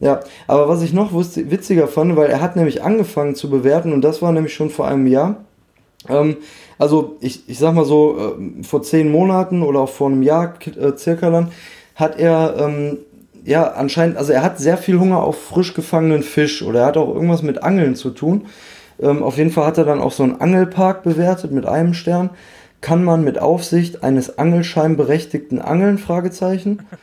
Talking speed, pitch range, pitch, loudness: 195 wpm, 145-175 Hz, 160 Hz, -16 LUFS